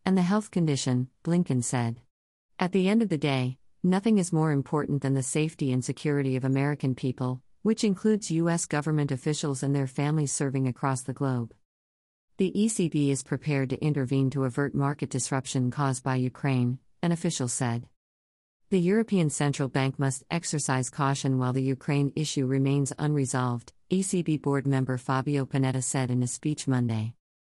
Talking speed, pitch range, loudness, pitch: 165 wpm, 130-155 Hz, -27 LUFS, 140 Hz